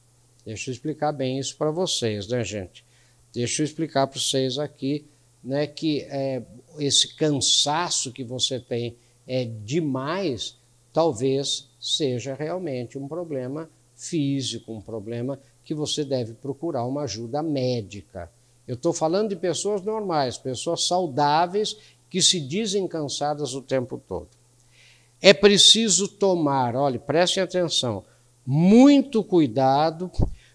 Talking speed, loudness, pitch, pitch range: 125 wpm, -23 LUFS, 140 Hz, 120-160 Hz